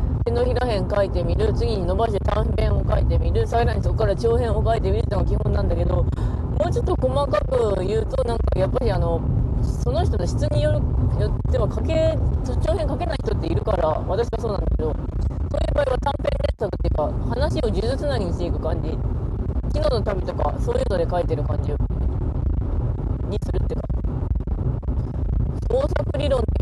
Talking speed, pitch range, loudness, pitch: 355 characters per minute, 80-105 Hz, -23 LUFS, 95 Hz